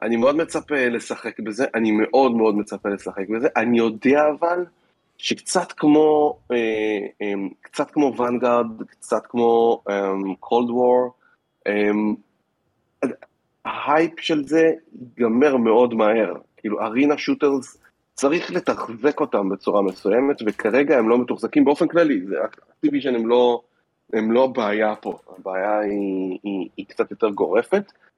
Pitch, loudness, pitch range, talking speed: 120 Hz, -21 LUFS, 105-145 Hz, 130 wpm